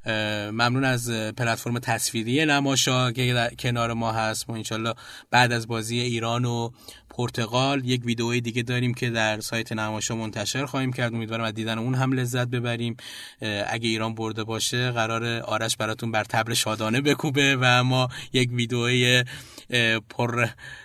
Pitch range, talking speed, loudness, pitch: 115-125 Hz, 145 wpm, -24 LUFS, 120 Hz